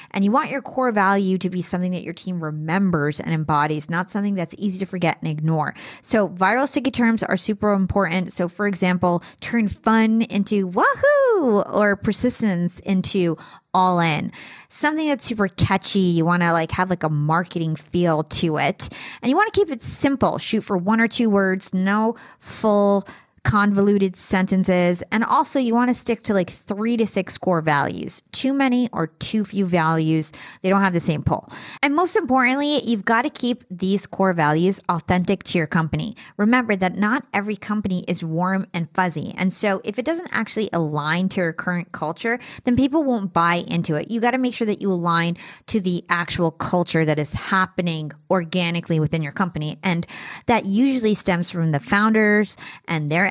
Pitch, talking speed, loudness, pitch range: 190 Hz, 190 wpm, -21 LUFS, 170-220 Hz